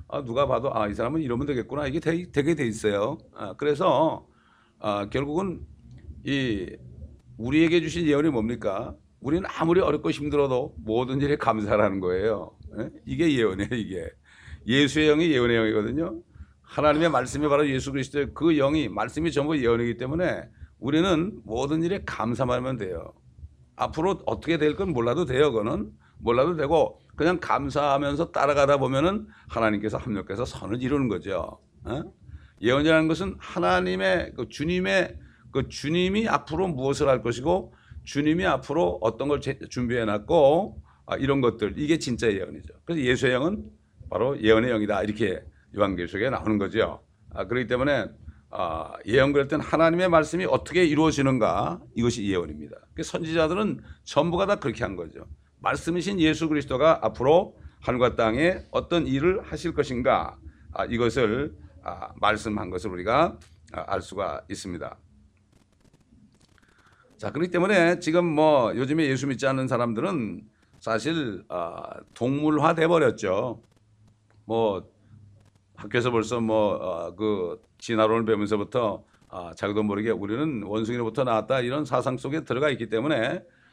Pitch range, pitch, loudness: 110-155 Hz, 130 Hz, -25 LUFS